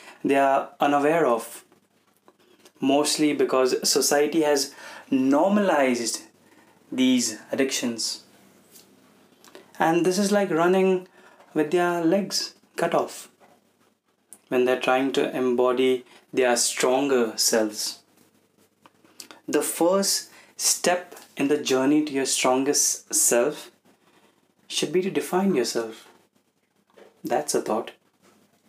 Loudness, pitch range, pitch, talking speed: -23 LUFS, 125-170 Hz, 140 Hz, 100 wpm